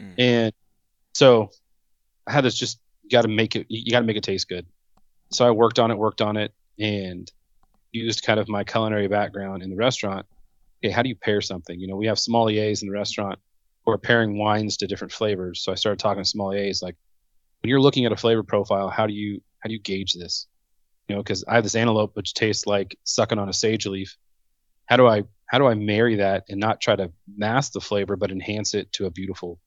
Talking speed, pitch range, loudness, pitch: 230 wpm, 95-110 Hz, -23 LUFS, 105 Hz